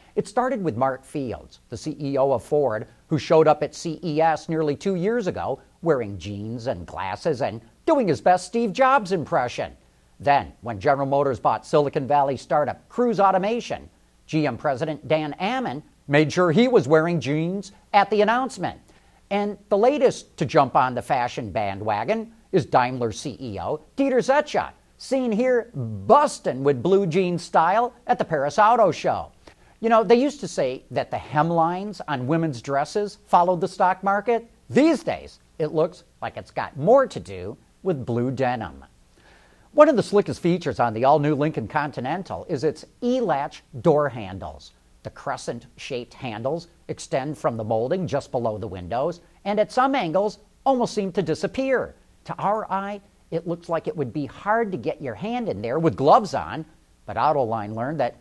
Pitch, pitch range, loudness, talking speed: 160 Hz, 135-205 Hz, -23 LUFS, 170 wpm